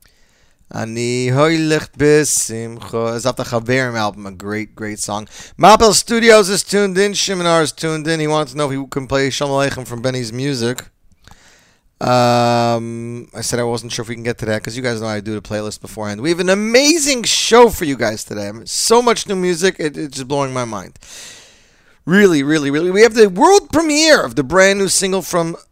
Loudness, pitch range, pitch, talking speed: -15 LUFS, 115-185 Hz, 135 Hz, 195 wpm